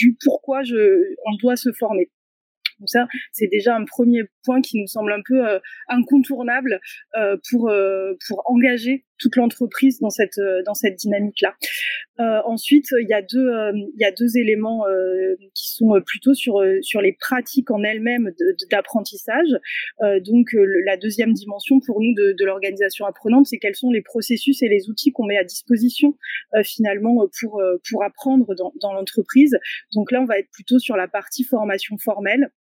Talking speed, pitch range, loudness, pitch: 185 wpm, 205-255 Hz, -19 LUFS, 225 Hz